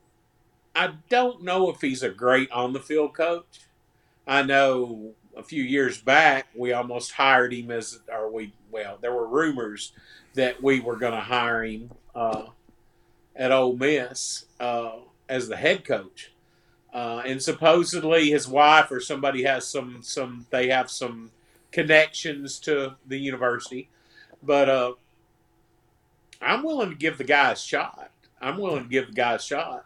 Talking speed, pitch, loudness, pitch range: 160 wpm, 130 Hz, -24 LUFS, 120-145 Hz